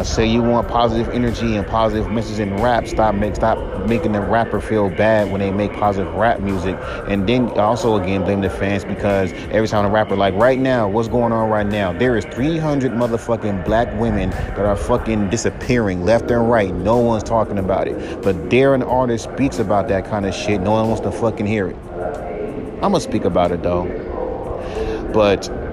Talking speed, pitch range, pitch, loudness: 200 wpm, 100-115 Hz, 110 Hz, -18 LUFS